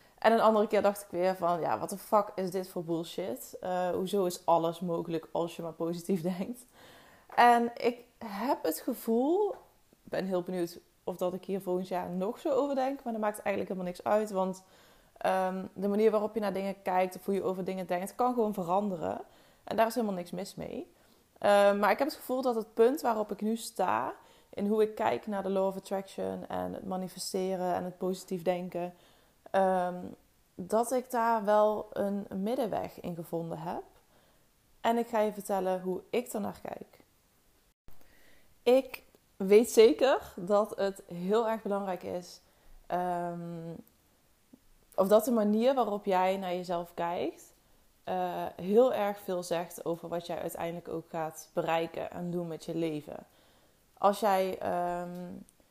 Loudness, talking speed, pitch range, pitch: -31 LUFS, 175 wpm, 180-215 Hz, 190 Hz